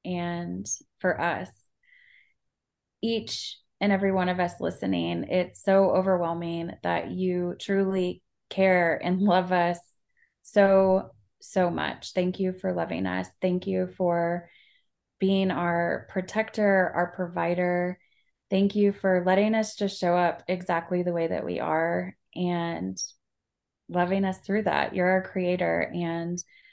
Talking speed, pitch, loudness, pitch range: 130 wpm, 180 Hz, -27 LUFS, 175-190 Hz